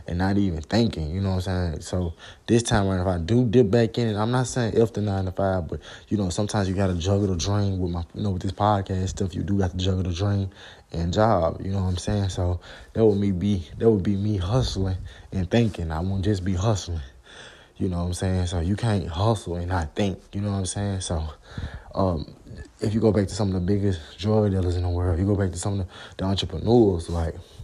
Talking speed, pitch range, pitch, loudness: 265 wpm, 90-105 Hz, 95 Hz, -25 LUFS